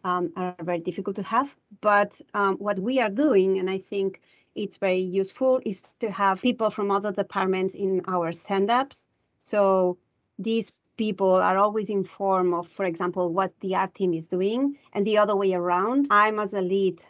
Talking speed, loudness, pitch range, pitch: 185 wpm, -25 LUFS, 185-210 Hz, 195 Hz